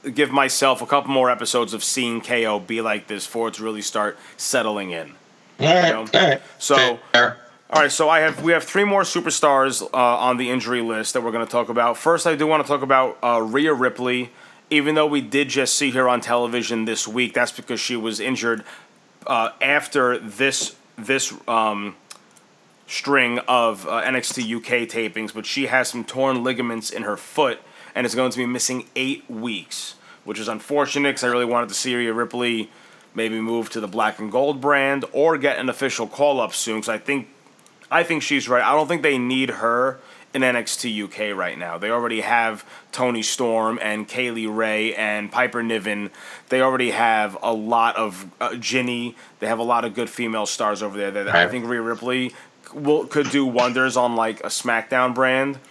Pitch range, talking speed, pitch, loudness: 115-135 Hz, 200 wpm, 120 Hz, -21 LUFS